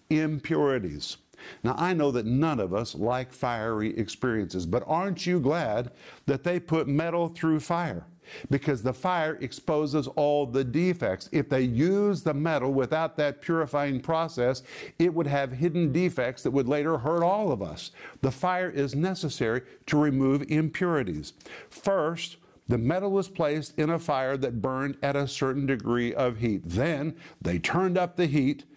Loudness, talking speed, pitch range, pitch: -28 LUFS, 165 wpm, 130-165 Hz, 150 Hz